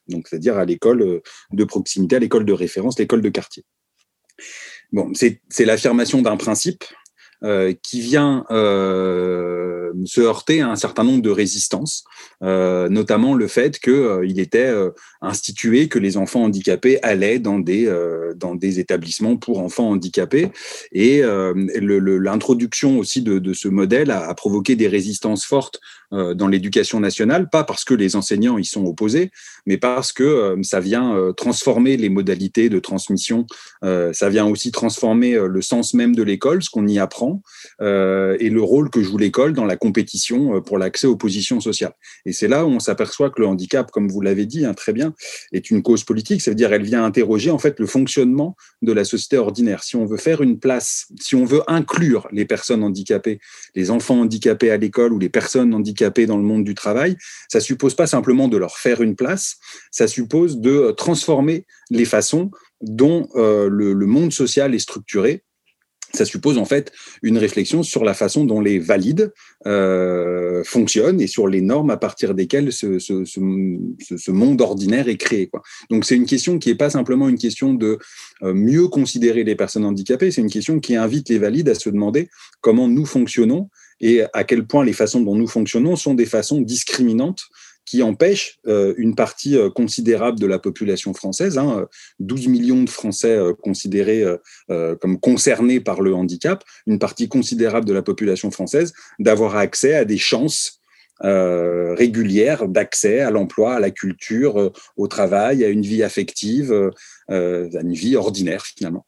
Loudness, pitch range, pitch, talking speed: -18 LUFS, 95-130 Hz, 110 Hz, 175 wpm